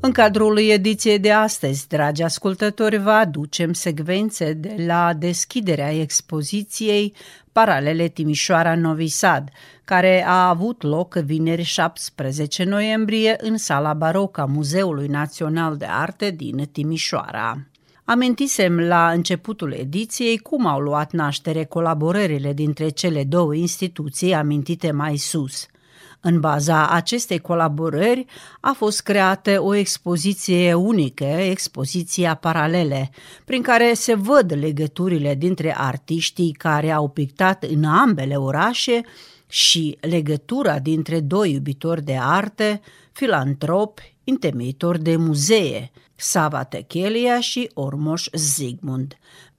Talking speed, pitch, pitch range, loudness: 110 wpm, 170 Hz, 150-200 Hz, -20 LUFS